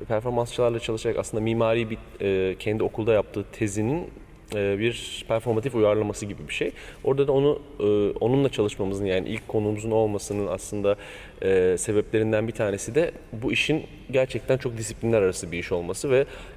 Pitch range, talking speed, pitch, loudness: 100-120 Hz, 140 wpm, 110 Hz, -25 LUFS